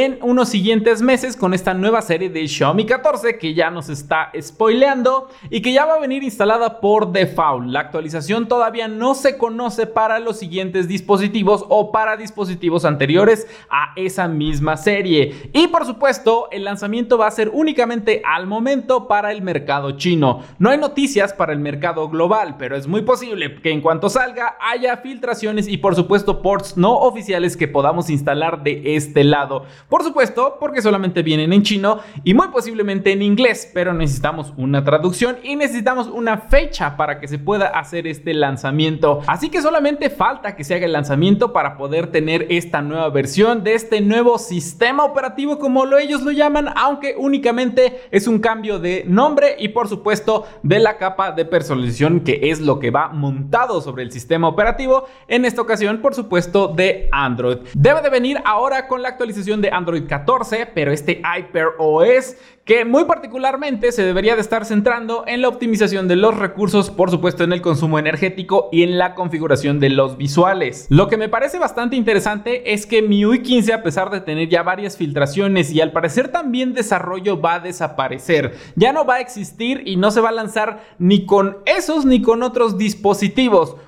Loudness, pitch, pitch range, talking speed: -17 LUFS, 205 Hz, 170-240 Hz, 185 wpm